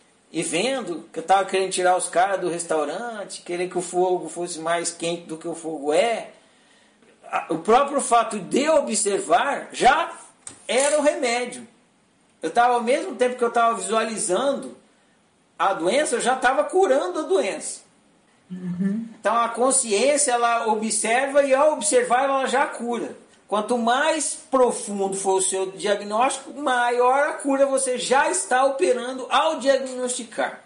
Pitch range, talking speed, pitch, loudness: 190-265 Hz, 155 wpm, 235 Hz, -22 LUFS